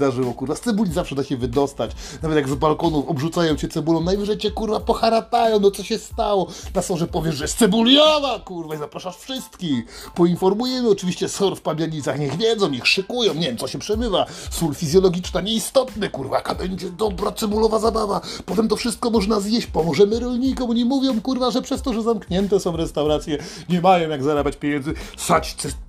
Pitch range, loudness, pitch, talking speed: 160-225 Hz, -21 LUFS, 190 Hz, 185 wpm